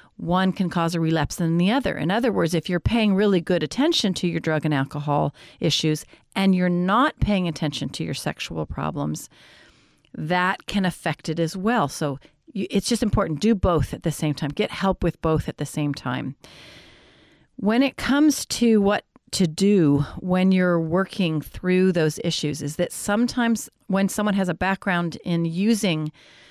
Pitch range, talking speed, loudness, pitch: 155-200 Hz, 180 wpm, -23 LUFS, 180 Hz